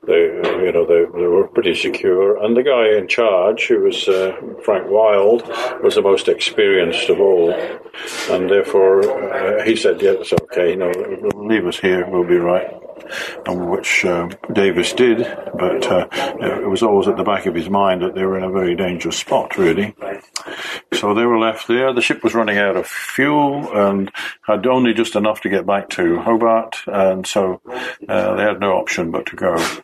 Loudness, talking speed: -17 LUFS, 200 wpm